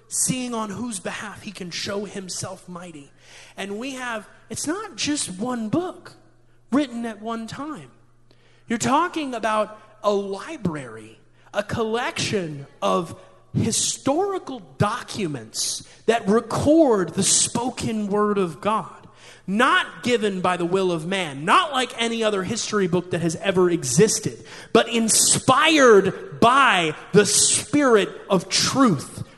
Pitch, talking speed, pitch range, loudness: 205 Hz, 125 wpm, 175-235 Hz, -21 LUFS